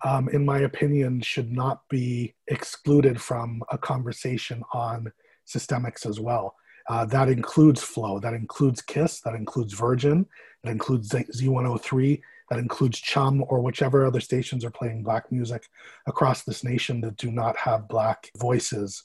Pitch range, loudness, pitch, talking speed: 115-135 Hz, -25 LUFS, 125 Hz, 150 wpm